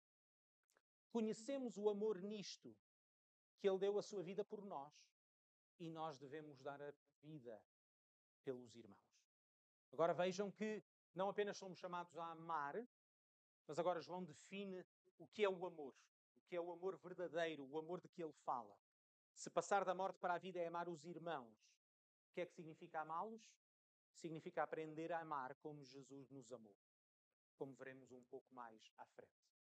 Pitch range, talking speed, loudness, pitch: 135-185 Hz, 165 wpm, -48 LUFS, 165 Hz